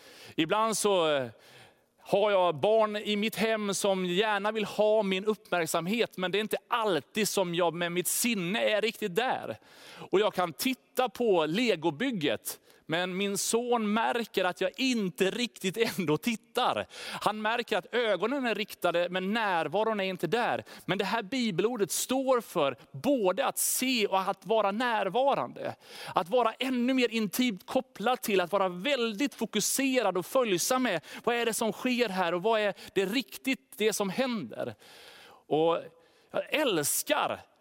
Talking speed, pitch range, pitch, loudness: 155 wpm, 190-240 Hz, 215 Hz, -29 LUFS